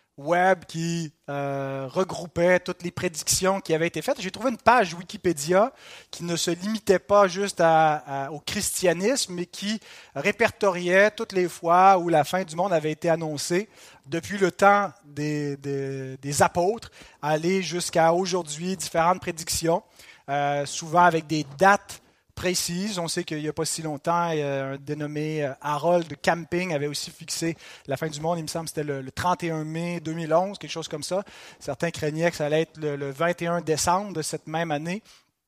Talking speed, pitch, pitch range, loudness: 175 wpm, 170 Hz, 150-180 Hz, -25 LUFS